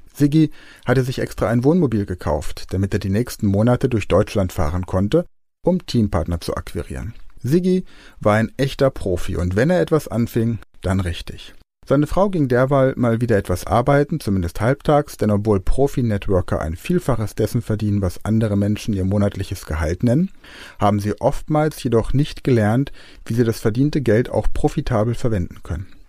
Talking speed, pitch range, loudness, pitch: 165 wpm, 100-135 Hz, -20 LUFS, 115 Hz